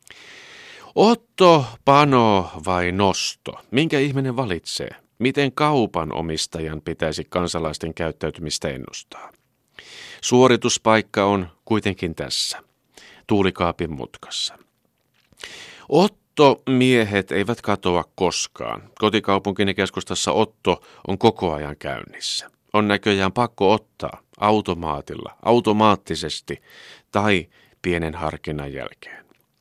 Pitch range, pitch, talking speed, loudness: 85-120 Hz, 100 Hz, 85 wpm, -21 LUFS